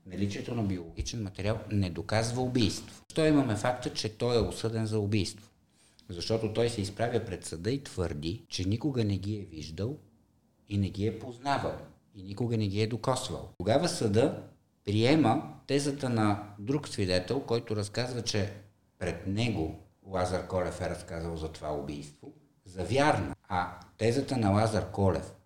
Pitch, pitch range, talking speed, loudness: 105 Hz, 95-115 Hz, 160 wpm, -31 LUFS